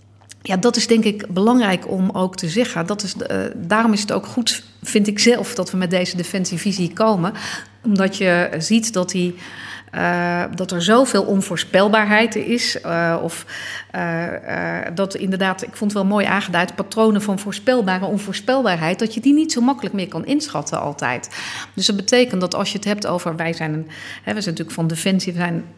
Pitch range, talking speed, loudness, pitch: 175-220 Hz, 195 wpm, -19 LUFS, 195 Hz